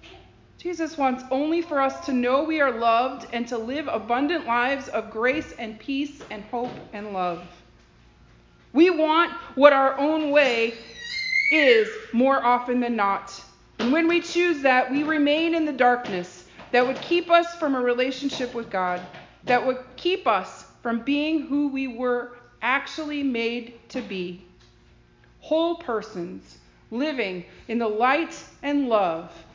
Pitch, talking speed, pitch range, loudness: 255 Hz, 150 wpm, 230-300 Hz, -23 LUFS